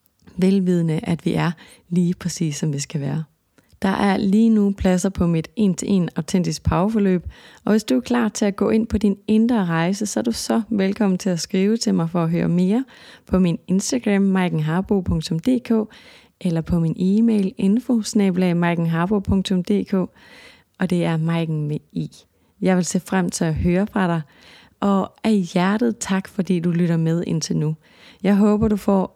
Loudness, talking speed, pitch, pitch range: -20 LUFS, 175 wpm, 190 Hz, 170-210 Hz